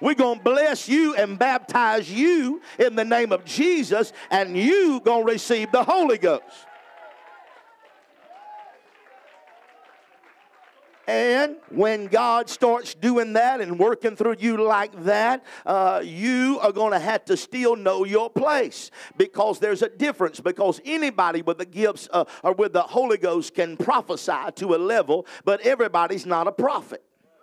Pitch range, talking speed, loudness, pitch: 205-295 Hz, 150 wpm, -22 LUFS, 235 Hz